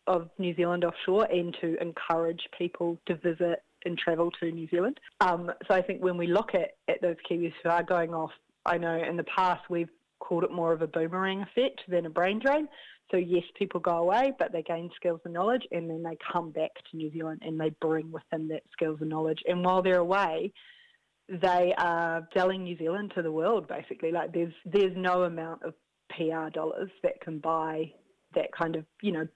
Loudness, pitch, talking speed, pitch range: -30 LUFS, 170 Hz, 215 wpm, 165-185 Hz